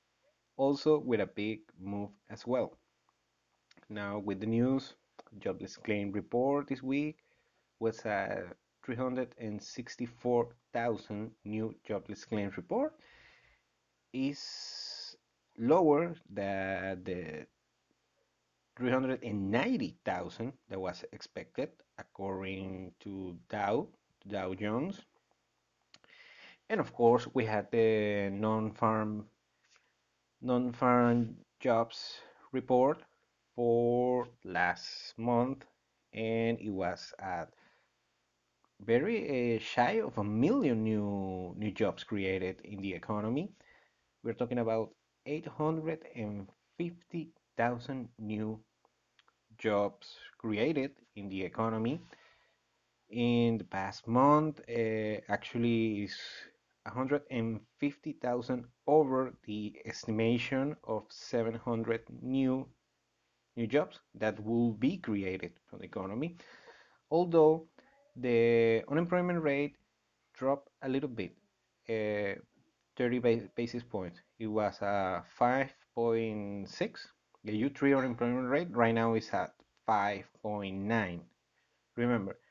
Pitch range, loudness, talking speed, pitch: 105-130 Hz, -34 LUFS, 95 wpm, 115 Hz